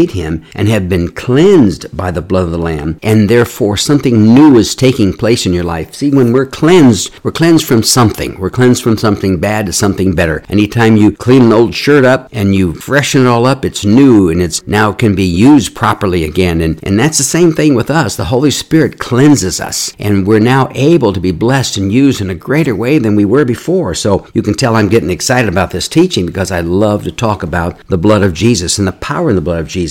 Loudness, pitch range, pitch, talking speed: -10 LUFS, 95-130 Hz, 105 Hz, 240 wpm